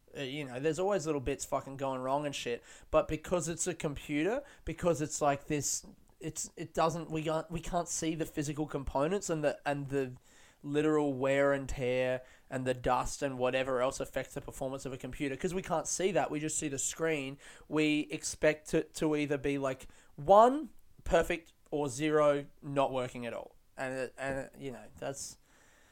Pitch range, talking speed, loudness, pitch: 135-160 Hz, 195 wpm, -33 LUFS, 145 Hz